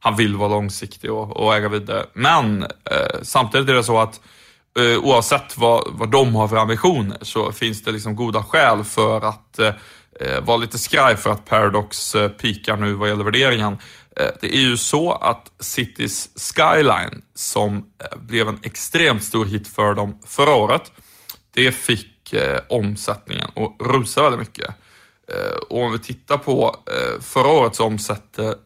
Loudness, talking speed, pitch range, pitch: -19 LUFS, 170 wpm, 105-120 Hz, 110 Hz